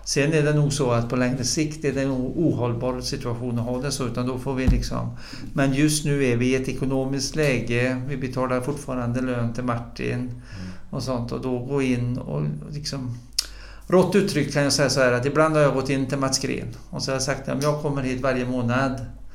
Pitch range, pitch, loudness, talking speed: 125-140 Hz, 130 Hz, -24 LUFS, 230 wpm